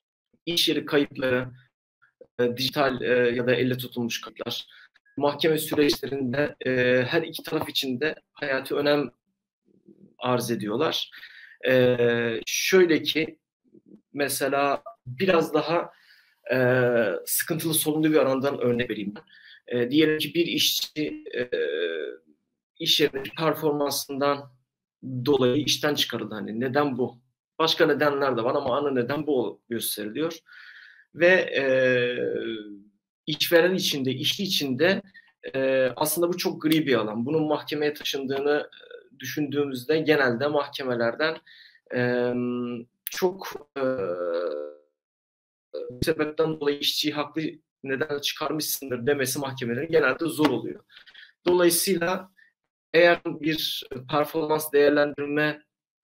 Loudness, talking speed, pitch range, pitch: -25 LUFS, 100 wpm, 125-160 Hz, 145 Hz